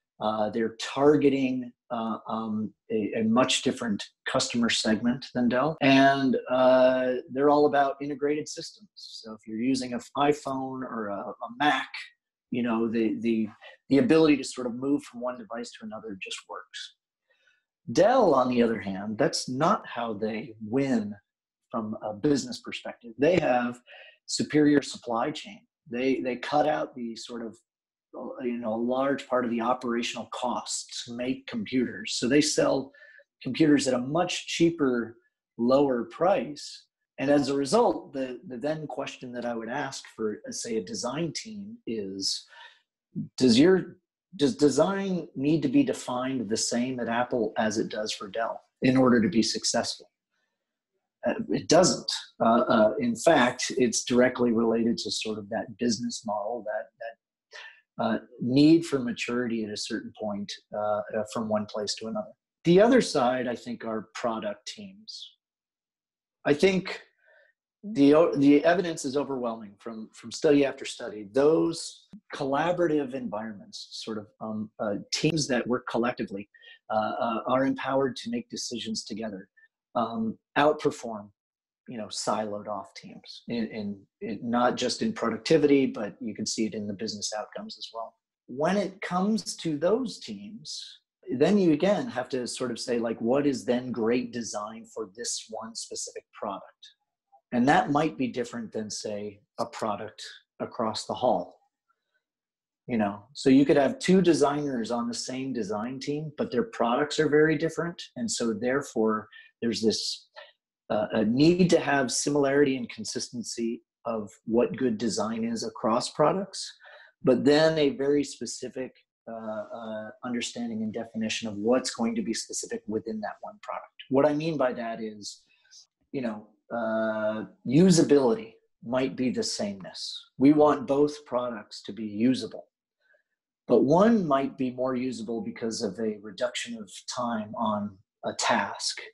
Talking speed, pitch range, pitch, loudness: 155 wpm, 115-165 Hz, 130 Hz, -27 LUFS